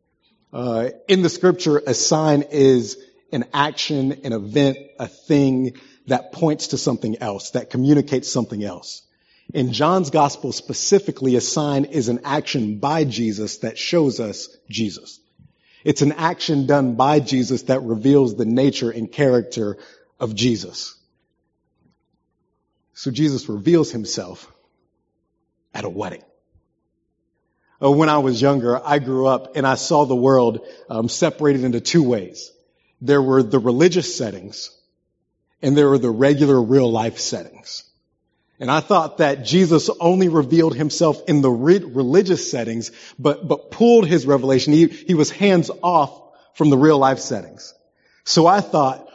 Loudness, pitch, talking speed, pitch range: -18 LUFS, 140 Hz, 145 wpm, 125-155 Hz